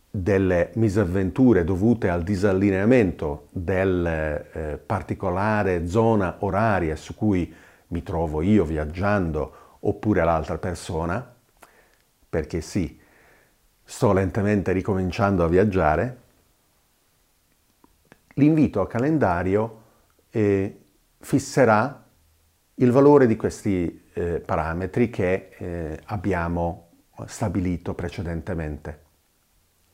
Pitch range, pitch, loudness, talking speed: 85-105 Hz, 95 Hz, -23 LUFS, 85 wpm